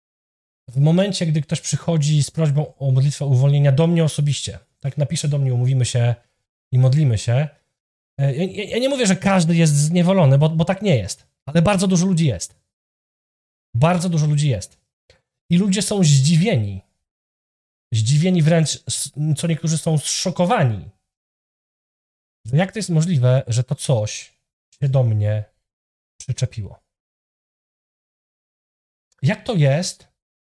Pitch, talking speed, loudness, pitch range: 145 Hz, 135 wpm, -19 LUFS, 120-165 Hz